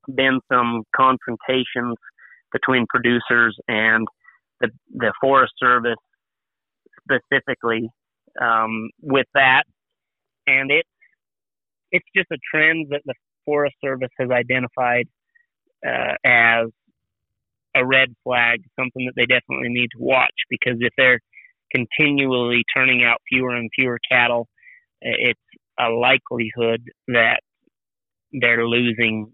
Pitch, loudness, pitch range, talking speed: 125 Hz, -18 LUFS, 115-130 Hz, 110 wpm